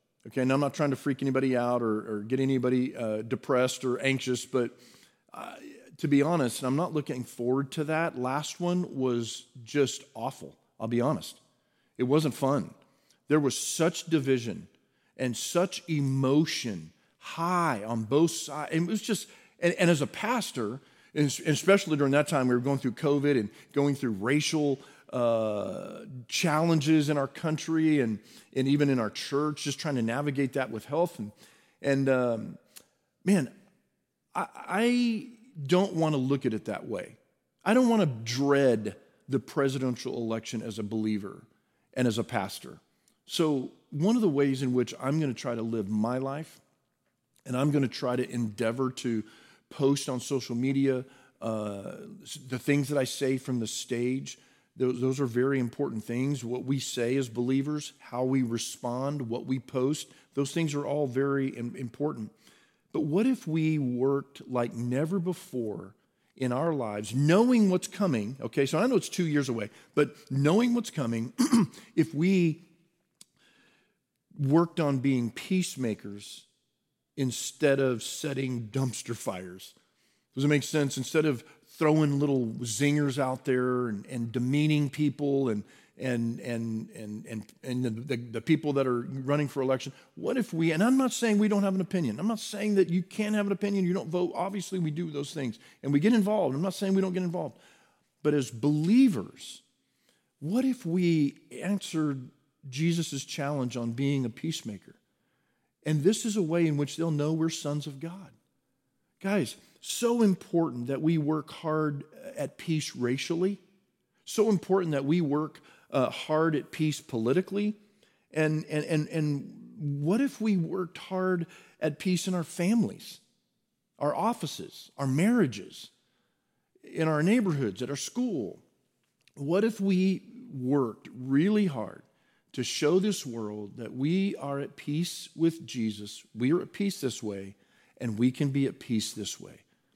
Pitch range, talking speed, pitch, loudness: 125-170 Hz, 165 wpm, 145 Hz, -29 LUFS